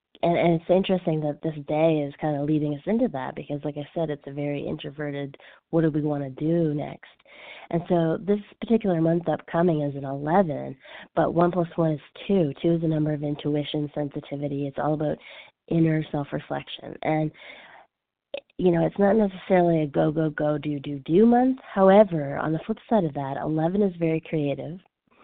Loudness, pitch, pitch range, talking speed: -25 LUFS, 160 Hz, 150-175 Hz, 195 wpm